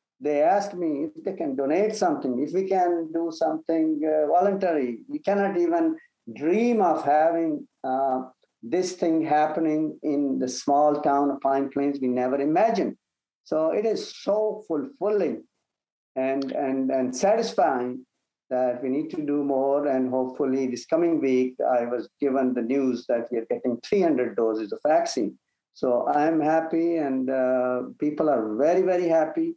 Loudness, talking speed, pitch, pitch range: -25 LUFS, 160 wpm, 150 Hz, 130-180 Hz